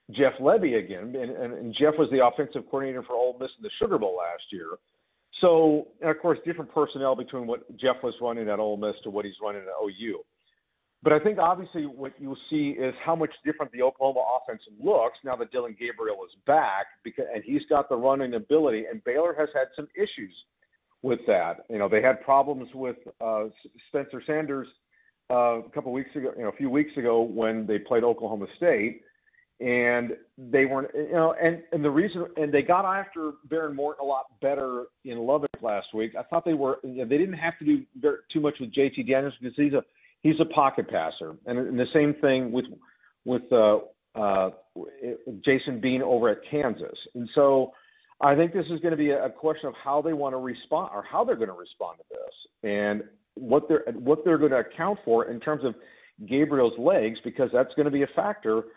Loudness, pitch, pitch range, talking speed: -26 LUFS, 140 Hz, 125-165 Hz, 210 wpm